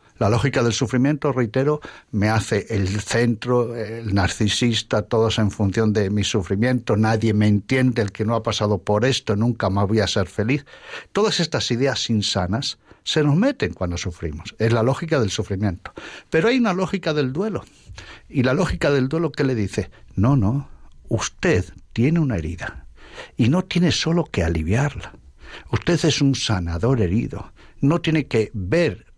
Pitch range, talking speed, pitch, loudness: 105-140 Hz, 170 wpm, 115 Hz, -21 LUFS